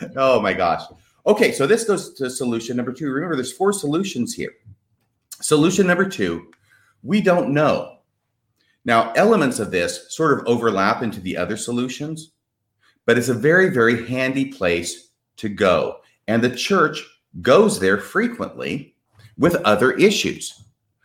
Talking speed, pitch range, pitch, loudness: 145 wpm, 115-160 Hz, 125 Hz, -19 LUFS